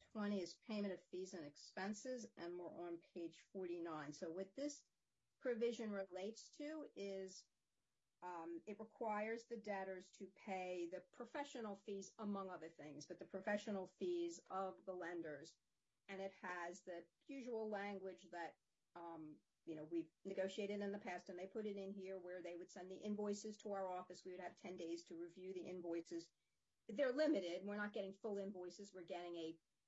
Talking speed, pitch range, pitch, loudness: 175 wpm, 175-210 Hz, 190 Hz, -50 LUFS